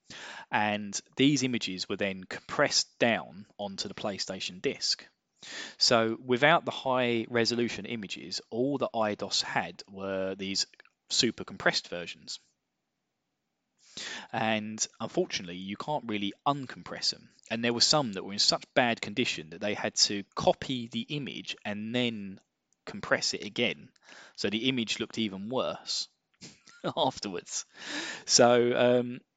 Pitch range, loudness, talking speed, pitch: 100-125 Hz, -29 LUFS, 130 wpm, 115 Hz